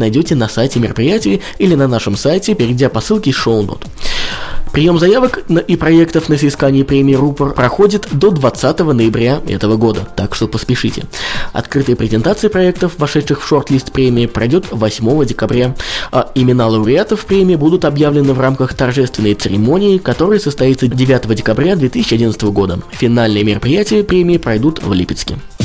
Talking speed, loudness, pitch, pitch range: 145 wpm, -13 LUFS, 130 Hz, 110-155 Hz